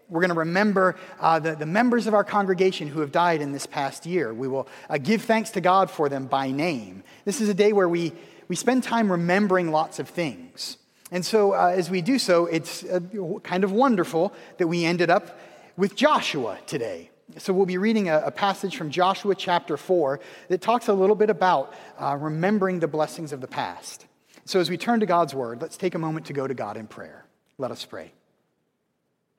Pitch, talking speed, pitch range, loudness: 180 Hz, 215 wpm, 160-200 Hz, -24 LUFS